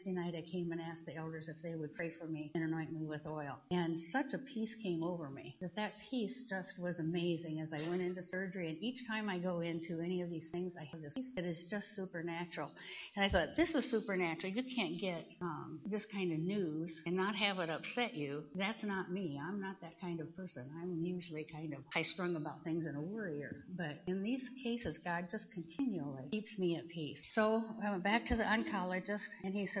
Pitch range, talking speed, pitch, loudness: 160-200 Hz, 230 wpm, 175 Hz, -40 LUFS